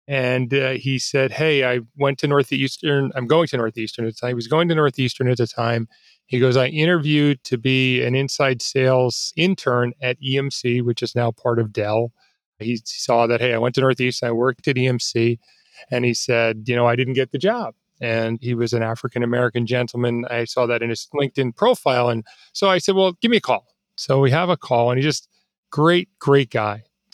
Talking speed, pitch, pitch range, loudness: 210 wpm, 125 Hz, 120-140 Hz, -20 LUFS